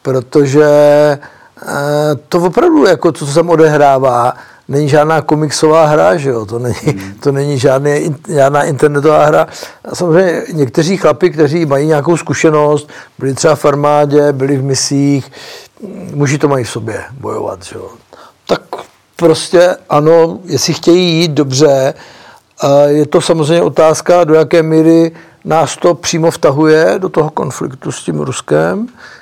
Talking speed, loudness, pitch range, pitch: 145 wpm, -10 LUFS, 140-165 Hz, 150 Hz